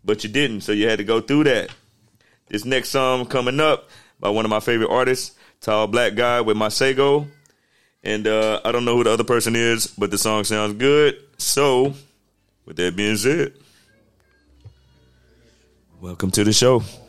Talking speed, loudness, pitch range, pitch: 180 wpm, -19 LUFS, 105-130 Hz, 110 Hz